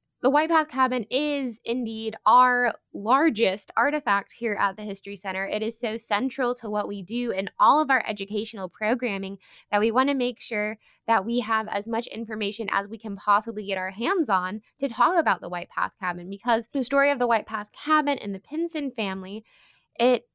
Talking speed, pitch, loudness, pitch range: 200 wpm, 225 Hz, -25 LUFS, 205-250 Hz